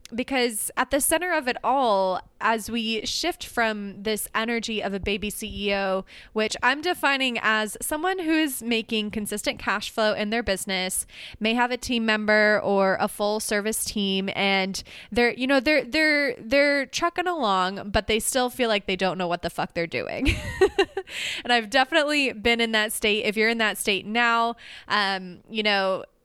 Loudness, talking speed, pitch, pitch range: -24 LUFS, 180 wpm, 220 Hz, 205-255 Hz